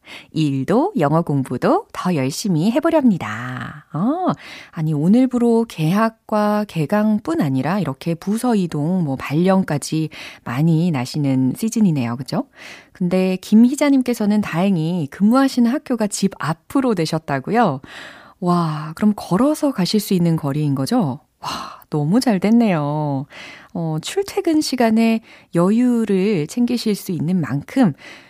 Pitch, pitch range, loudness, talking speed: 190 Hz, 155-230 Hz, -19 LUFS, 265 characters per minute